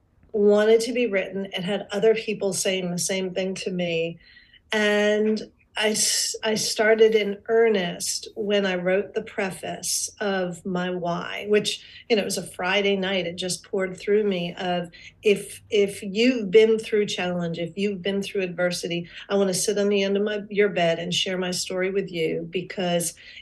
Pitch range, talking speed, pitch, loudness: 180-210 Hz, 180 wpm, 200 Hz, -24 LUFS